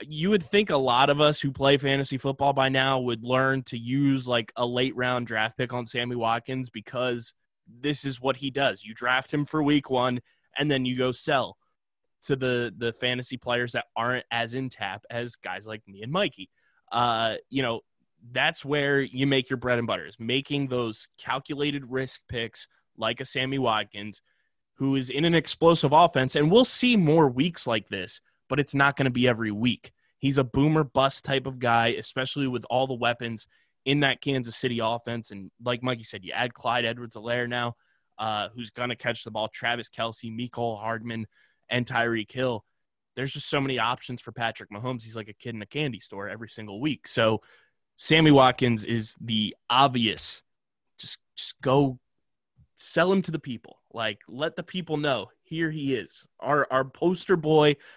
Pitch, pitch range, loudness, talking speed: 125 Hz, 115-140 Hz, -26 LUFS, 195 wpm